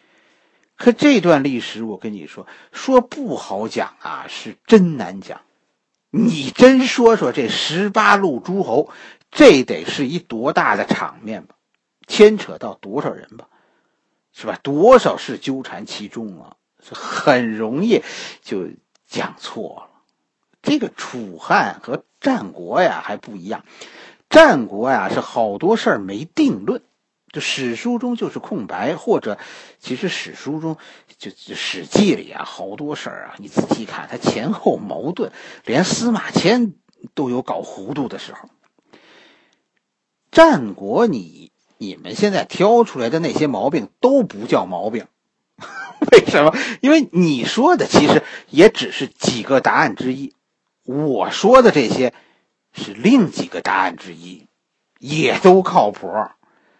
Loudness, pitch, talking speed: -17 LUFS, 215 Hz, 200 characters per minute